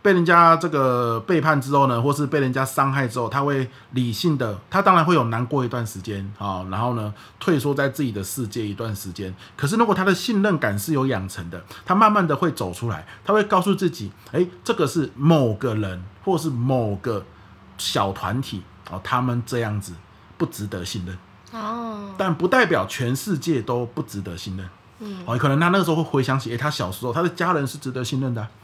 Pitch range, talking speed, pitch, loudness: 105-160 Hz, 310 characters per minute, 130 Hz, -22 LUFS